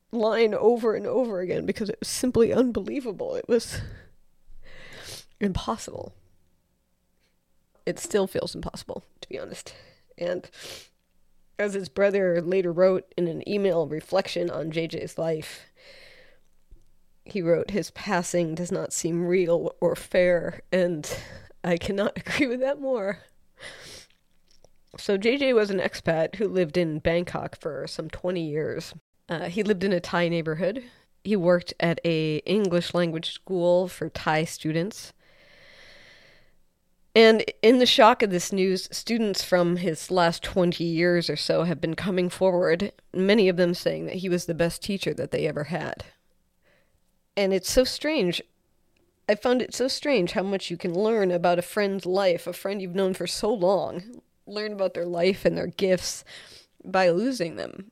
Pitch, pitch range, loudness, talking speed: 180 Hz, 170-205 Hz, -25 LUFS, 155 wpm